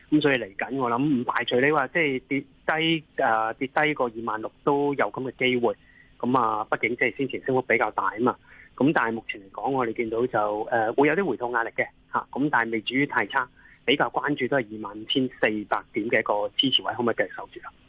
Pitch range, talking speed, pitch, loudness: 110-140 Hz, 350 characters per minute, 130 Hz, -25 LUFS